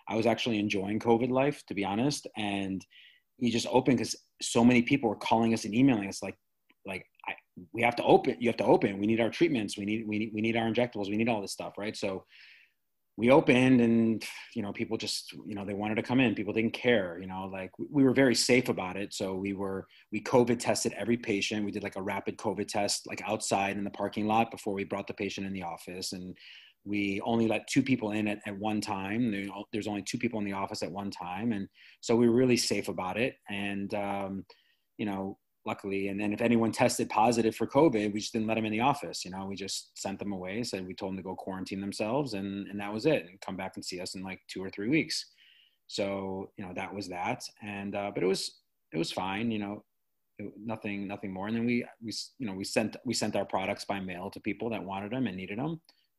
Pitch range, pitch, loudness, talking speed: 100-115 Hz, 105 Hz, -31 LUFS, 250 wpm